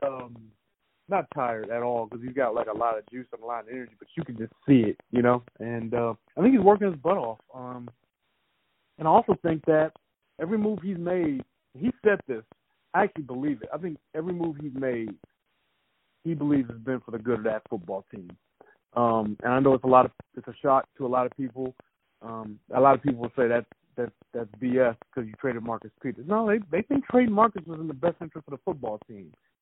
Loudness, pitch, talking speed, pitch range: -27 LUFS, 130 Hz, 235 wpm, 120-165 Hz